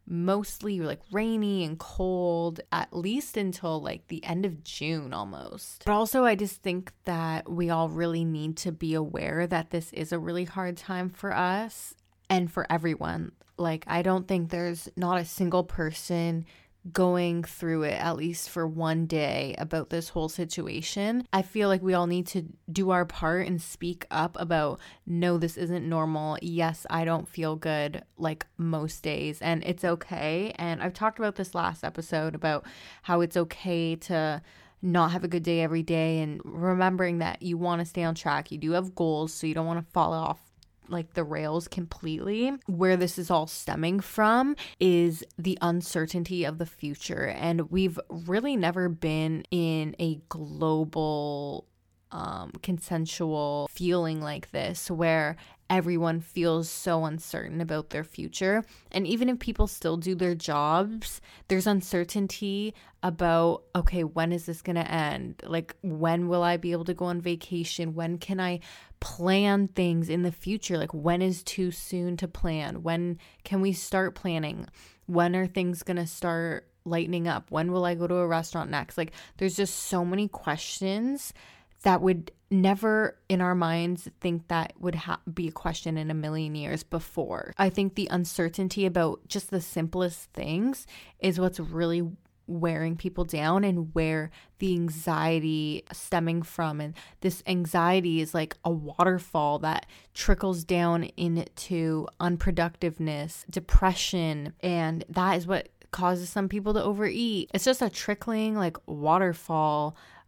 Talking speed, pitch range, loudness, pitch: 165 wpm, 165-185 Hz, -29 LUFS, 170 Hz